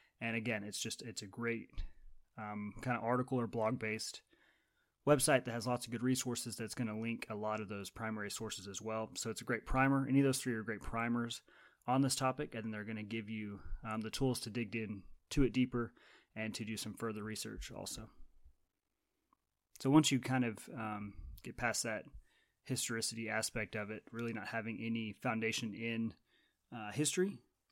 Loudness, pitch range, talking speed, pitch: -38 LUFS, 110-120 Hz, 195 wpm, 115 Hz